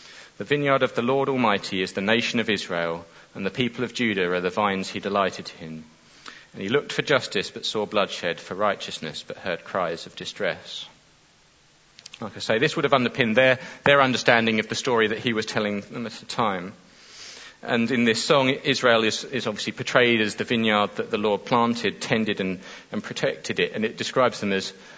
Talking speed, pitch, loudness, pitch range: 200 wpm, 110 Hz, -23 LUFS, 100-125 Hz